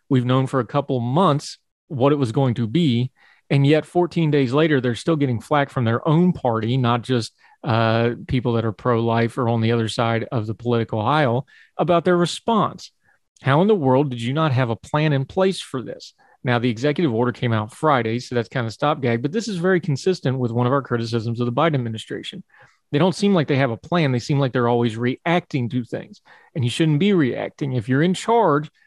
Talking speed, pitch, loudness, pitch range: 230 wpm, 135 Hz, -20 LUFS, 120-155 Hz